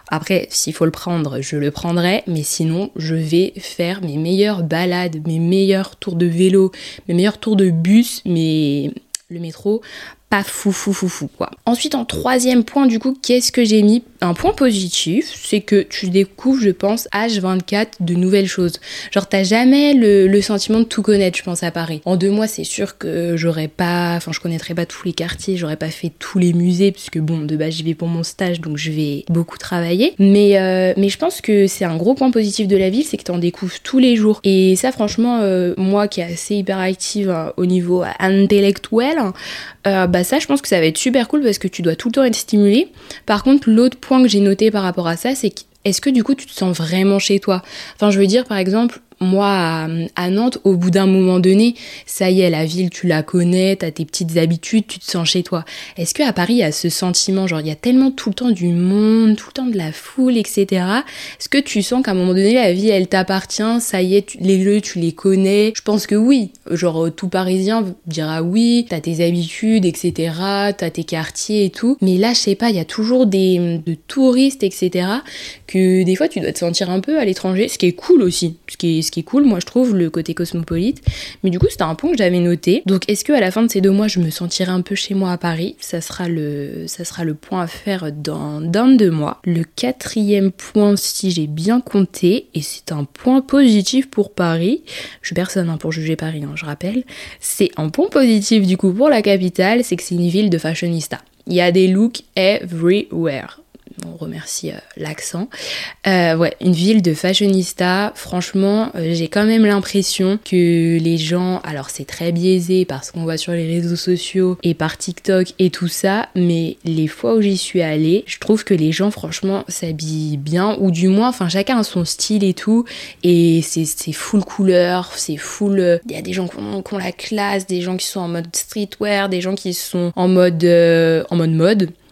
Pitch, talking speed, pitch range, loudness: 185 Hz, 230 wpm, 170-210 Hz, -16 LUFS